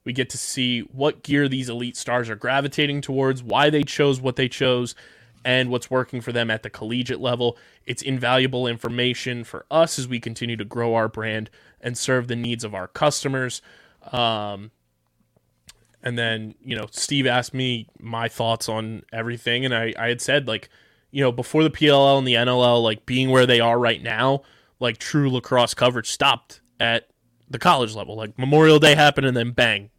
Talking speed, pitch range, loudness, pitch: 190 wpm, 115-130 Hz, -21 LUFS, 120 Hz